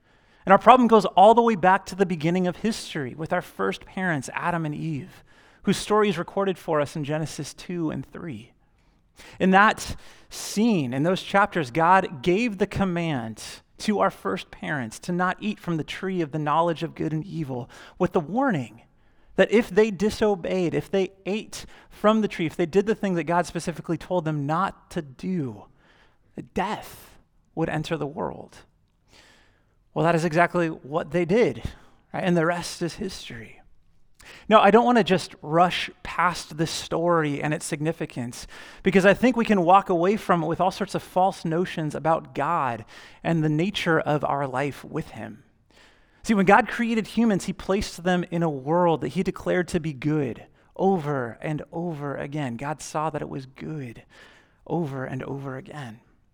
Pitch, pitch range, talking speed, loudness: 170 Hz, 150-190 Hz, 180 wpm, -24 LUFS